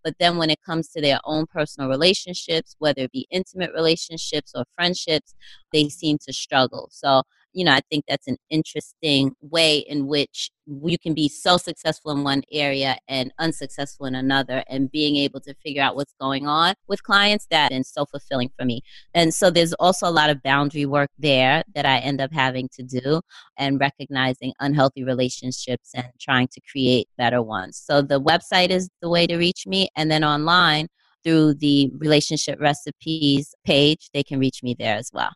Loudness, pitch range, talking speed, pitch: -21 LUFS, 135-160 Hz, 190 wpm, 145 Hz